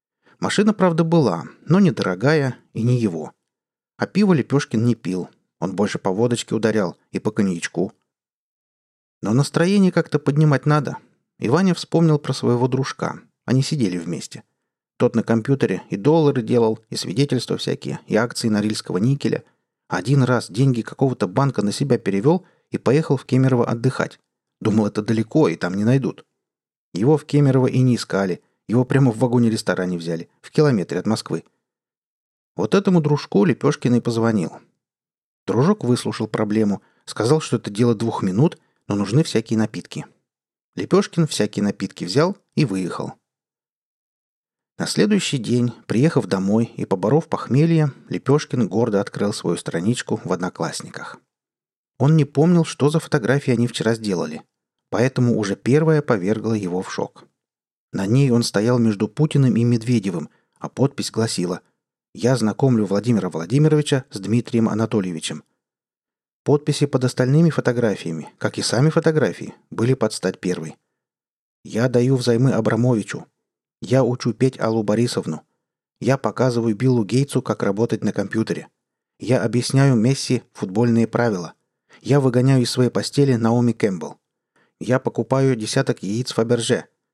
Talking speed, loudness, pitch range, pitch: 140 wpm, -20 LUFS, 110-140 Hz, 120 Hz